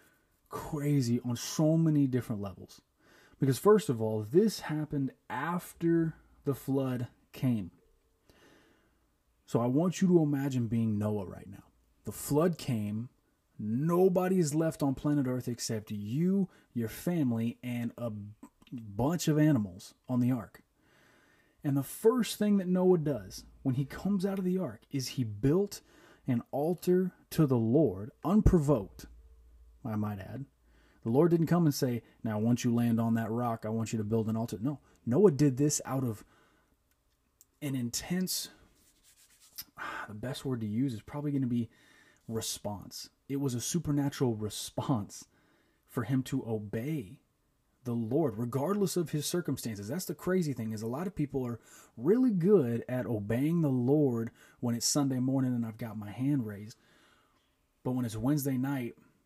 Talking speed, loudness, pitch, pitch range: 160 wpm, -31 LUFS, 130 Hz, 115-150 Hz